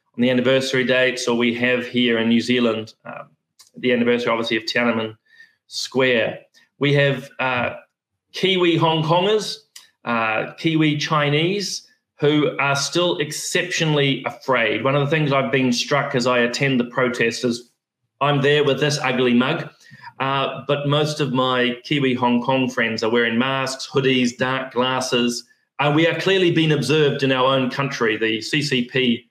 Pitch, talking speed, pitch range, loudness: 130 Hz, 160 wpm, 120-150 Hz, -19 LUFS